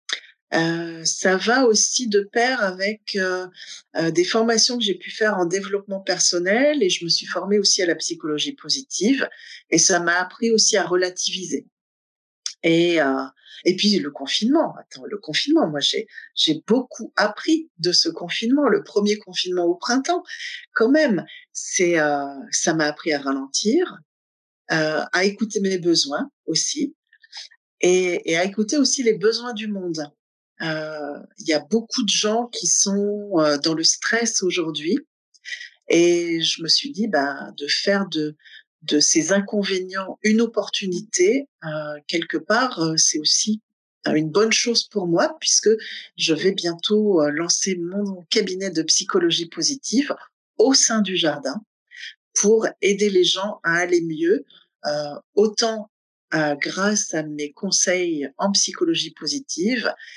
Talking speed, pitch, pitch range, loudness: 155 wpm, 190 Hz, 165-225 Hz, -20 LUFS